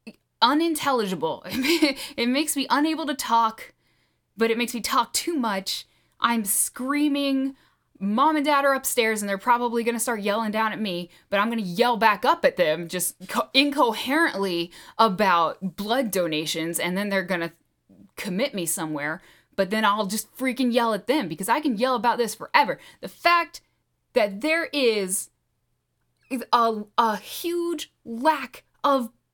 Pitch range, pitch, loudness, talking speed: 200-275 Hz, 235 Hz, -24 LUFS, 160 wpm